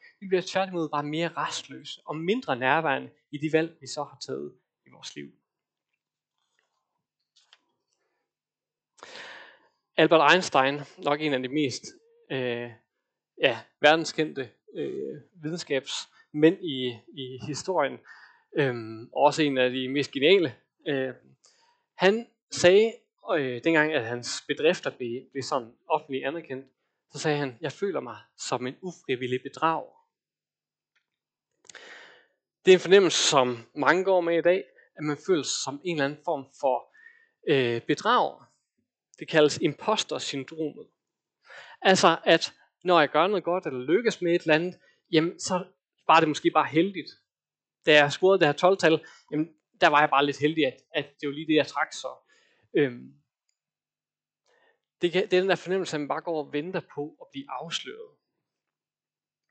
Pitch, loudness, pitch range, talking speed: 155 Hz, -26 LUFS, 135-180 Hz, 145 wpm